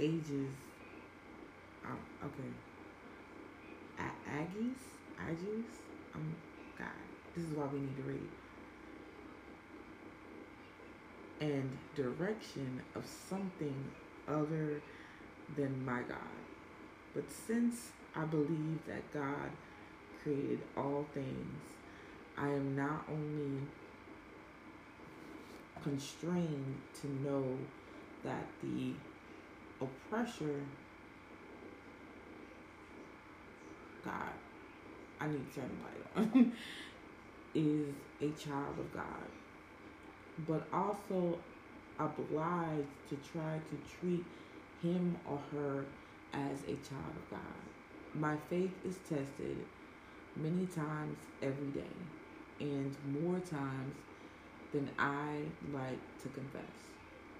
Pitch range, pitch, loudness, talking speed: 140-165 Hz, 150 Hz, -41 LUFS, 90 wpm